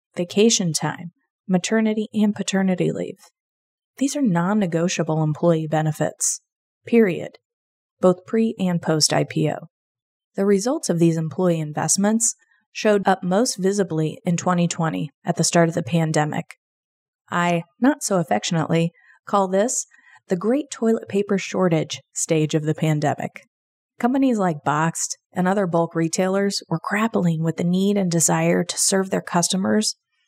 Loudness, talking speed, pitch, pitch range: -21 LUFS, 135 wpm, 180 Hz, 165-205 Hz